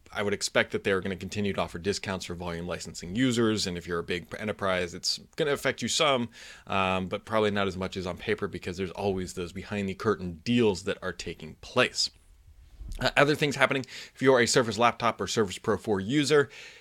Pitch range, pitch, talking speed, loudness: 90-115 Hz, 100 Hz, 220 wpm, -28 LUFS